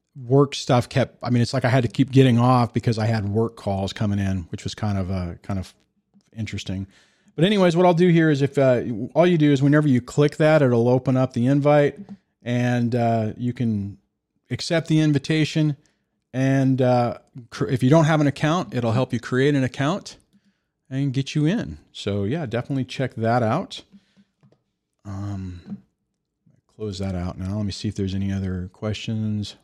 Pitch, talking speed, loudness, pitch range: 125 Hz, 195 wpm, -21 LUFS, 105-145 Hz